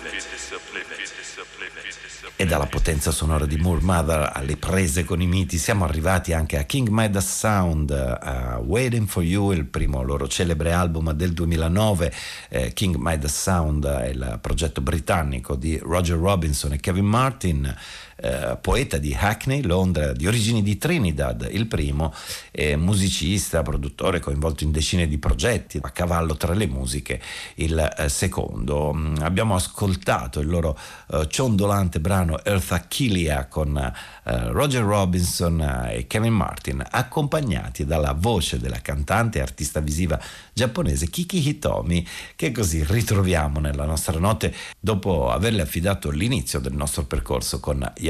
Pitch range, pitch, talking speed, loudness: 75-100 Hz, 85 Hz, 135 wpm, -23 LUFS